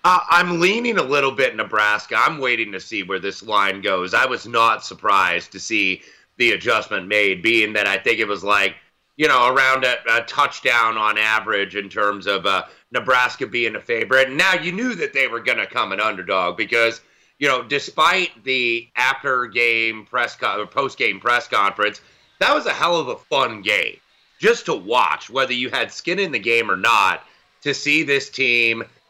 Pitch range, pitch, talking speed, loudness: 105-175 Hz, 120 Hz, 200 wpm, -18 LUFS